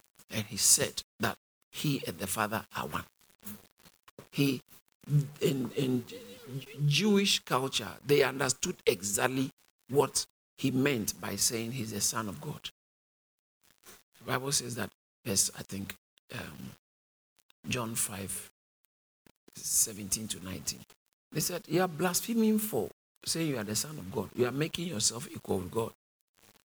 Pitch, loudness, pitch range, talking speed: 120 Hz, -31 LUFS, 100-145 Hz, 135 wpm